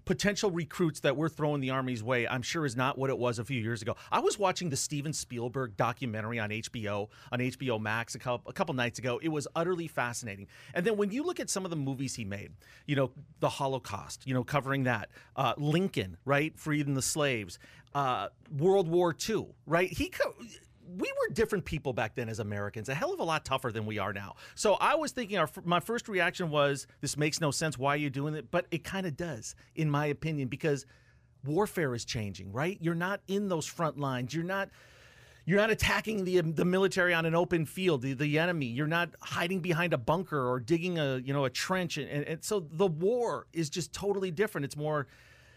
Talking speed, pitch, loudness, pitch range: 220 wpm, 150 Hz, -32 LUFS, 125-175 Hz